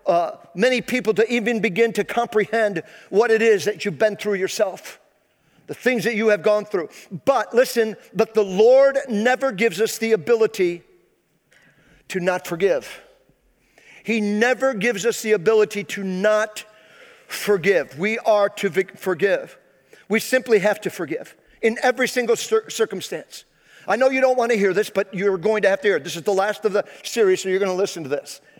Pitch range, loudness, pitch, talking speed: 200-235 Hz, -20 LUFS, 215 Hz, 185 wpm